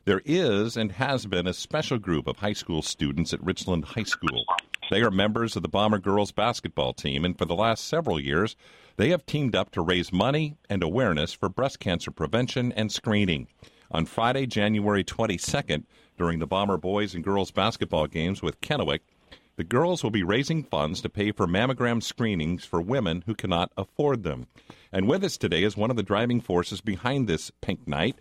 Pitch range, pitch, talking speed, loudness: 90-120 Hz, 105 Hz, 195 wpm, -27 LUFS